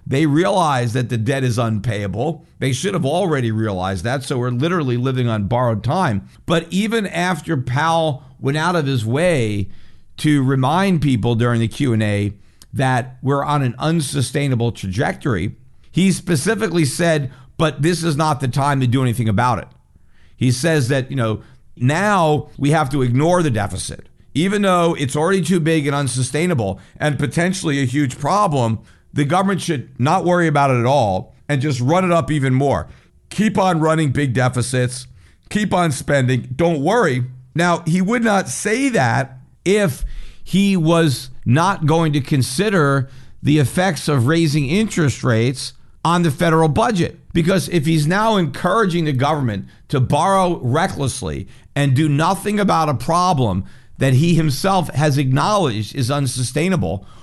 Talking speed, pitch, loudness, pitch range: 160 wpm, 145 Hz, -18 LUFS, 125-170 Hz